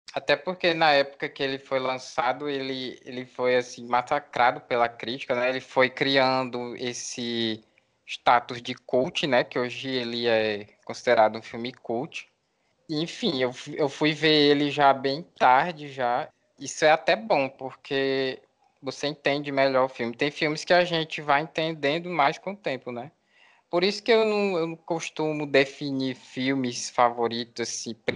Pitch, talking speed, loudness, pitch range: 135 Hz, 165 wpm, -25 LUFS, 125-150 Hz